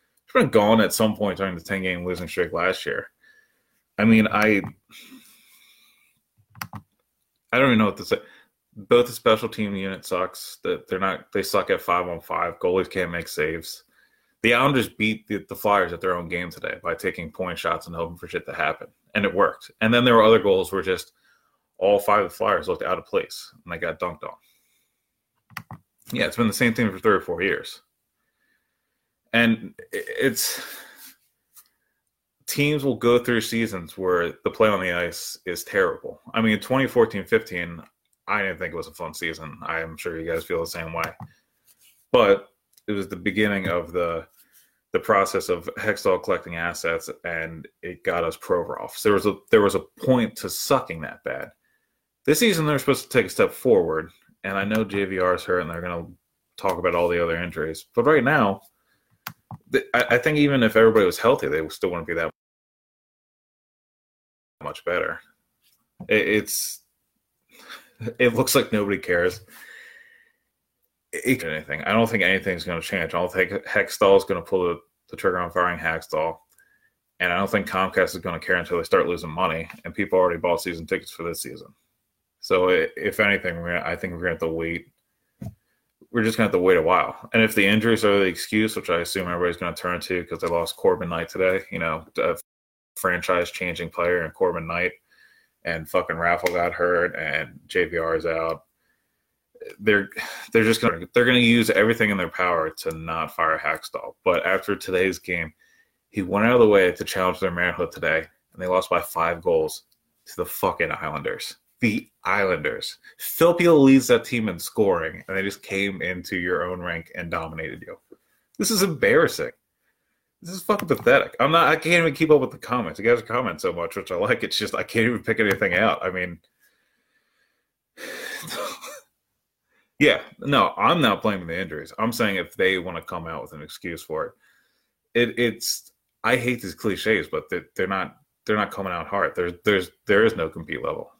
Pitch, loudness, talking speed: 120 Hz, -23 LUFS, 195 wpm